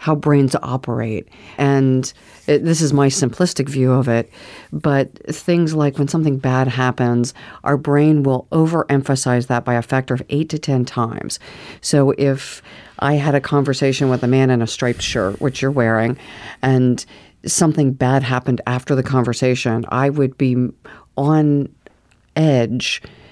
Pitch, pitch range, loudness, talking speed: 135 Hz, 125-145 Hz, -17 LUFS, 155 wpm